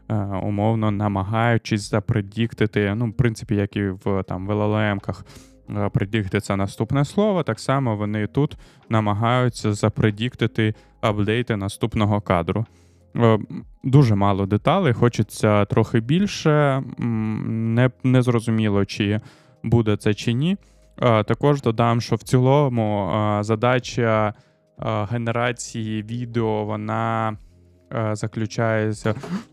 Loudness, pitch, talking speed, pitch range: -22 LUFS, 110 Hz, 95 wpm, 105-120 Hz